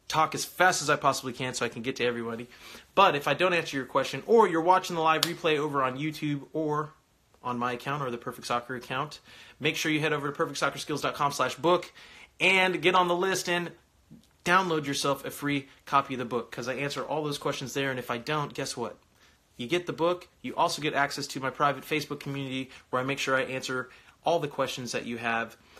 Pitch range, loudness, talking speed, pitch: 130-155 Hz, -28 LUFS, 225 wpm, 140 Hz